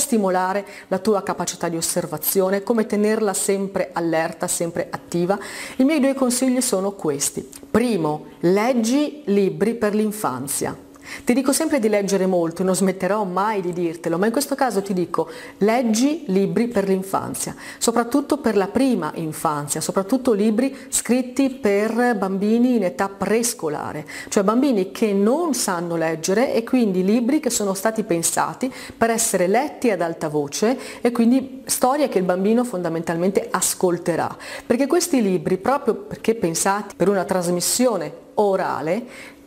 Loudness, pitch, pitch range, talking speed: -21 LUFS, 205 Hz, 185-245 Hz, 145 wpm